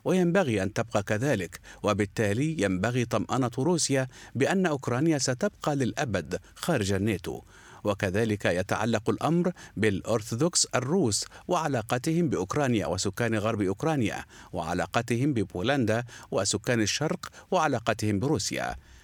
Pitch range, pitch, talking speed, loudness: 105-145 Hz, 115 Hz, 95 wpm, -28 LUFS